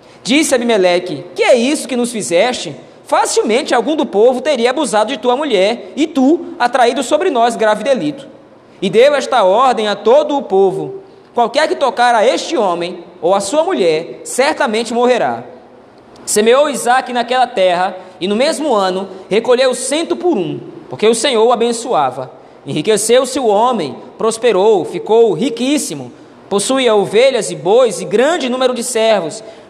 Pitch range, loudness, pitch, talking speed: 220-305 Hz, -13 LUFS, 250 Hz, 155 wpm